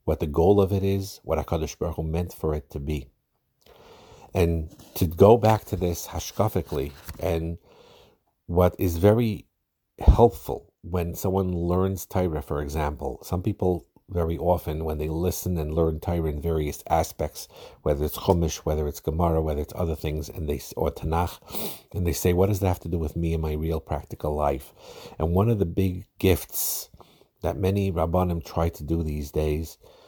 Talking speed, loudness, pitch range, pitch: 180 wpm, -26 LUFS, 80-95 Hz, 85 Hz